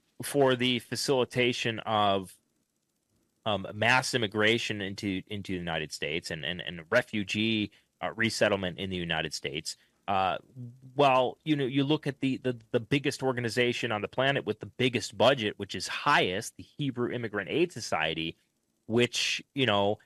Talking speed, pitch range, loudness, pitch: 155 wpm, 100-130 Hz, -29 LUFS, 115 Hz